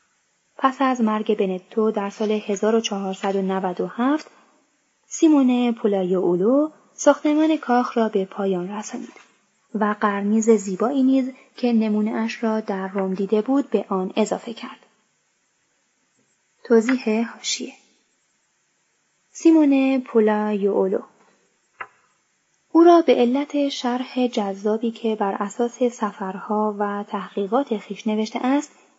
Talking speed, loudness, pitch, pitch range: 105 wpm, -21 LUFS, 220 Hz, 205-255 Hz